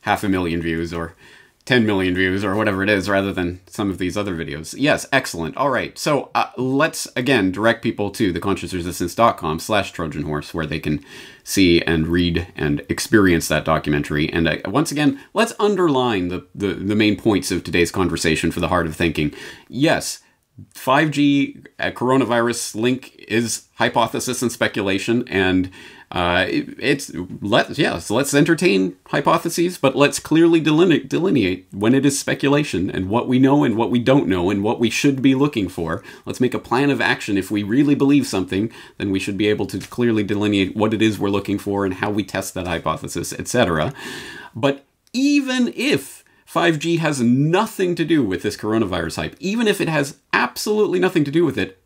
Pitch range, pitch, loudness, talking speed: 90-135 Hz, 105 Hz, -19 LUFS, 185 wpm